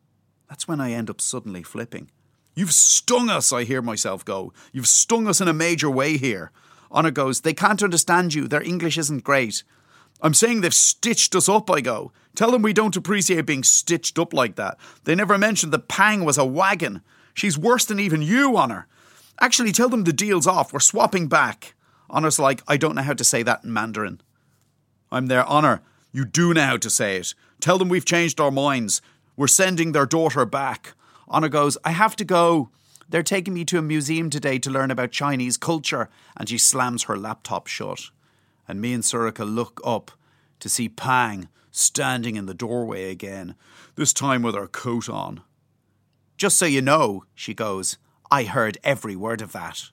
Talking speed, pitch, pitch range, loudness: 195 wpm, 145 Hz, 125-175 Hz, -20 LUFS